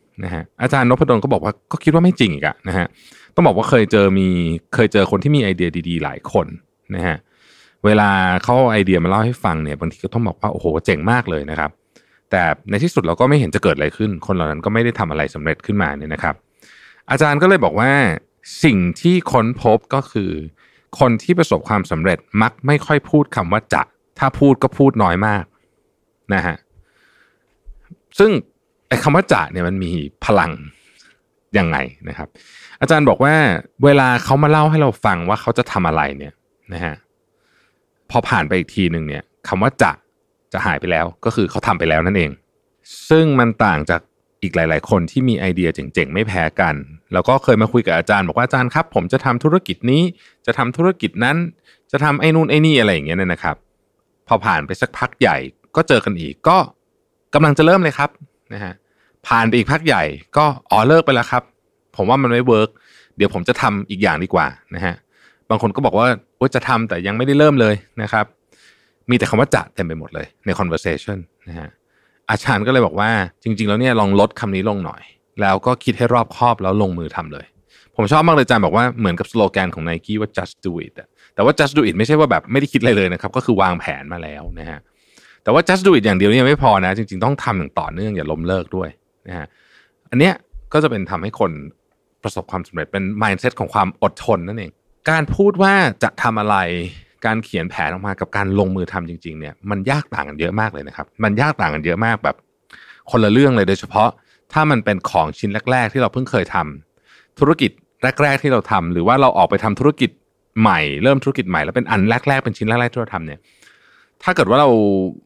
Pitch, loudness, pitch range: 110 Hz, -16 LUFS, 90-130 Hz